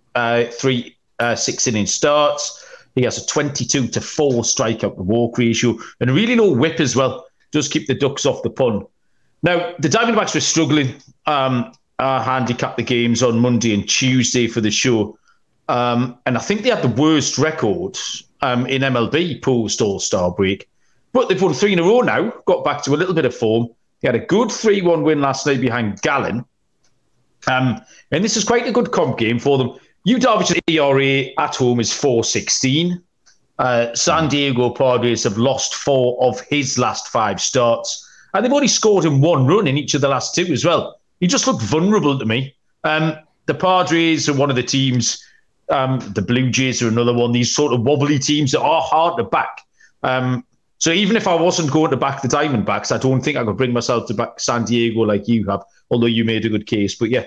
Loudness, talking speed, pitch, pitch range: -17 LUFS, 205 wpm, 130 Hz, 120-155 Hz